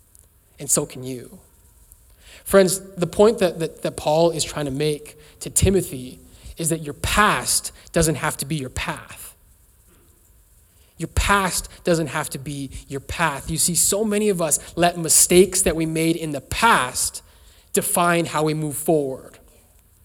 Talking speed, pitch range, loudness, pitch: 160 wpm, 120-170 Hz, -20 LUFS, 155 Hz